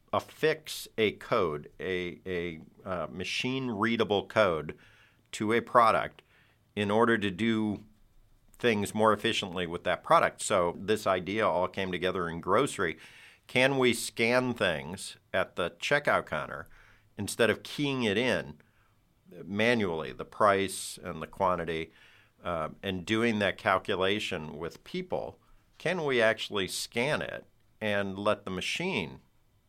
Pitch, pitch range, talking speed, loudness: 105 Hz, 95-115 Hz, 130 wpm, -29 LUFS